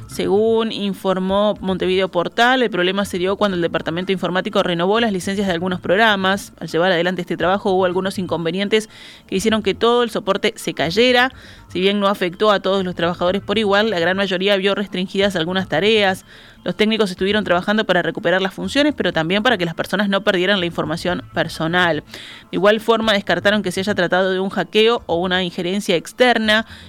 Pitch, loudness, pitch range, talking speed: 190 Hz, -18 LUFS, 180-210 Hz, 190 wpm